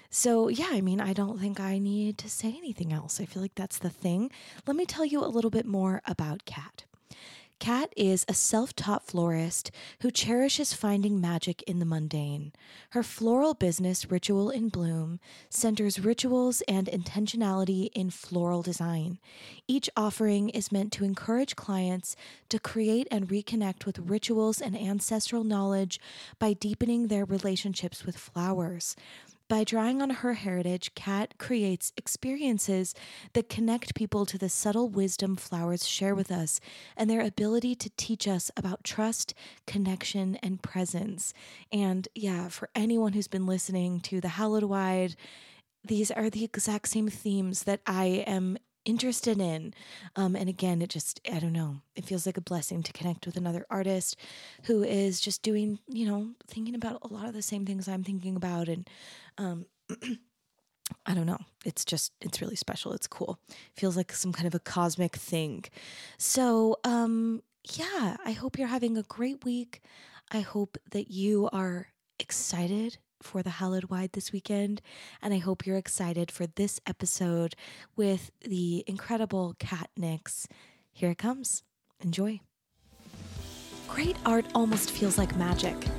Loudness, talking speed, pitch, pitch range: -31 LUFS, 160 wpm, 200 Hz, 180-220 Hz